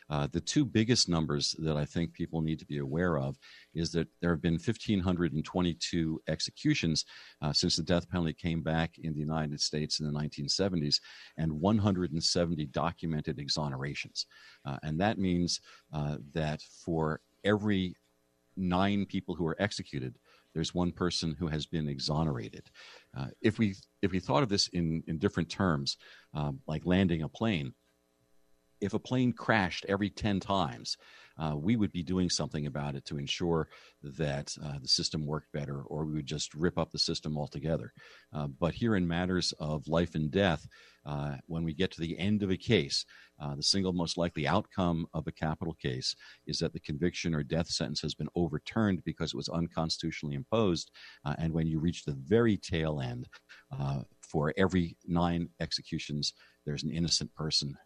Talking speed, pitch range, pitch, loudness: 175 wpm, 75-90 Hz, 80 Hz, -32 LUFS